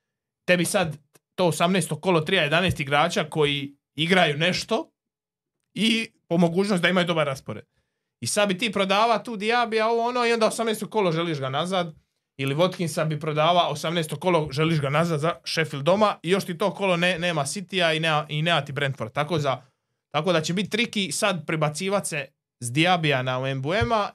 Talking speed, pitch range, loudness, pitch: 185 wpm, 150-195 Hz, -23 LUFS, 170 Hz